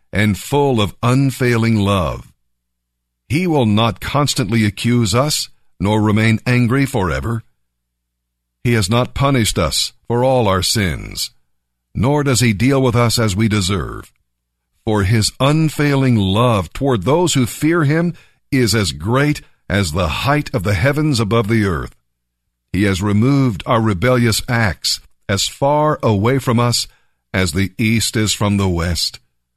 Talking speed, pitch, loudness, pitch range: 145 wpm, 110 Hz, -16 LUFS, 95-130 Hz